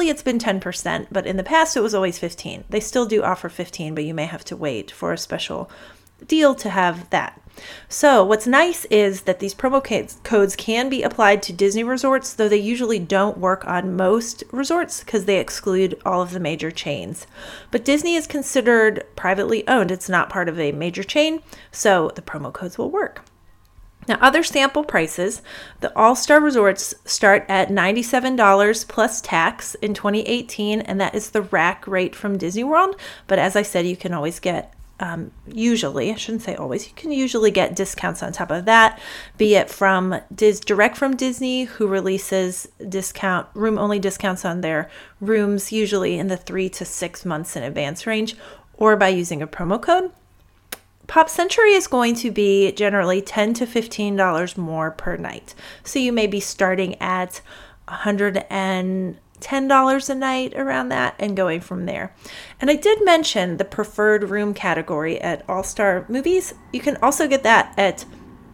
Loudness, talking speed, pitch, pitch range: -20 LUFS, 175 wpm, 205 Hz, 185-240 Hz